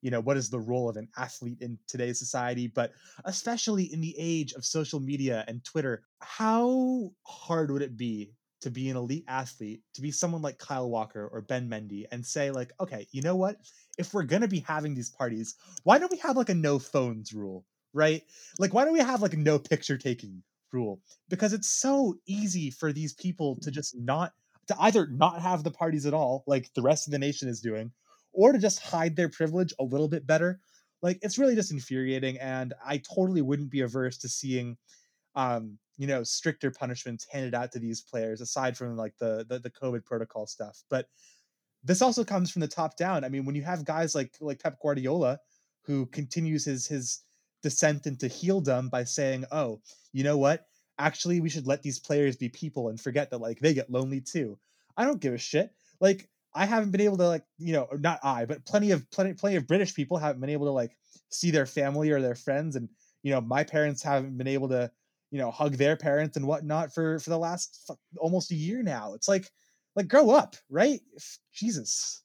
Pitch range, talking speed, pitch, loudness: 125-170 Hz, 215 wpm, 145 Hz, -29 LUFS